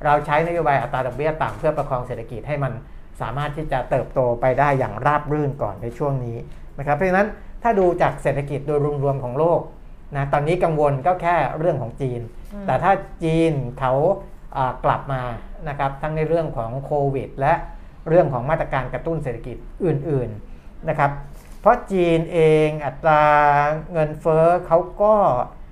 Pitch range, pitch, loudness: 130-165 Hz, 145 Hz, -21 LUFS